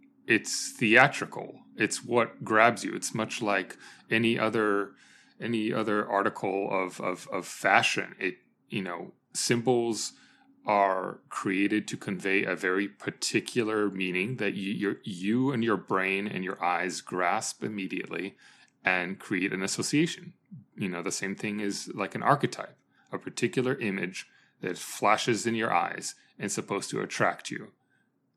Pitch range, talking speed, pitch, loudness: 100-120 Hz, 140 wpm, 105 Hz, -29 LUFS